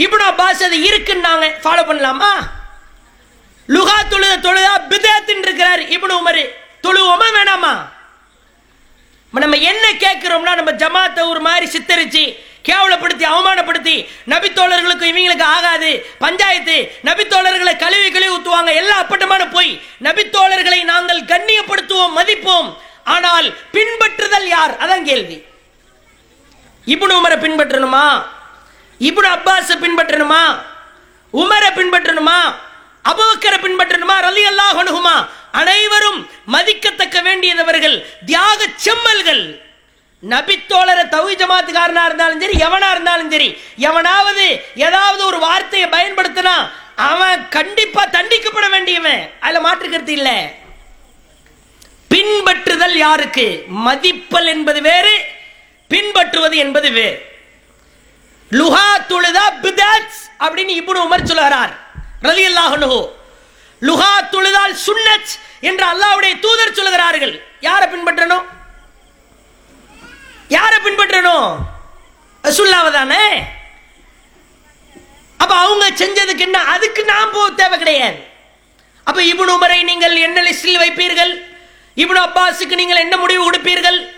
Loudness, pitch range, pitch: -11 LUFS, 335-390 Hz, 360 Hz